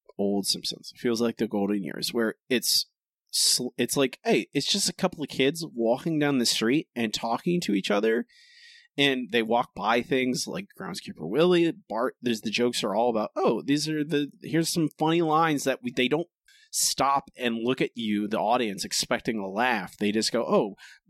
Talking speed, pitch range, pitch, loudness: 195 wpm, 120-165 Hz, 140 Hz, -26 LUFS